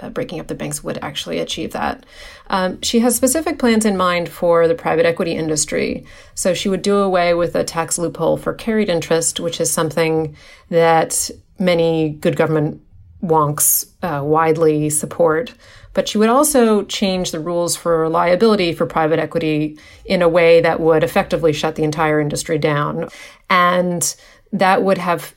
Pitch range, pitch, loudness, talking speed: 160-190 Hz, 170 Hz, -17 LUFS, 170 wpm